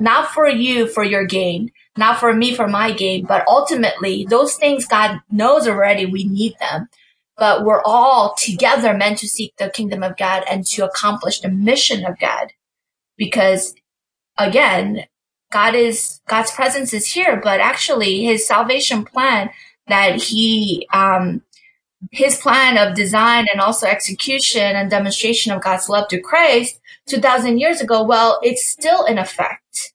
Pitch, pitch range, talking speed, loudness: 220 Hz, 195-255 Hz, 155 wpm, -15 LUFS